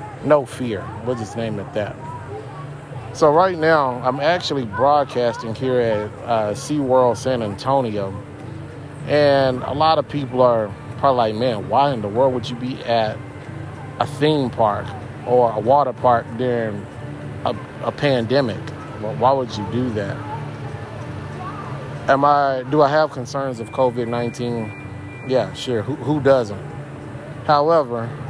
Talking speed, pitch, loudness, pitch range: 150 wpm, 130 Hz, -20 LUFS, 115-145 Hz